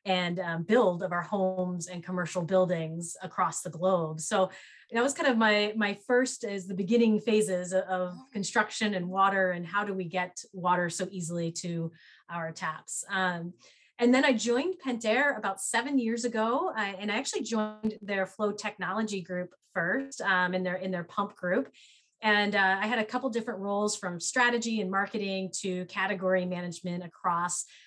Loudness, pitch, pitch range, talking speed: -29 LUFS, 195 Hz, 180-220 Hz, 175 wpm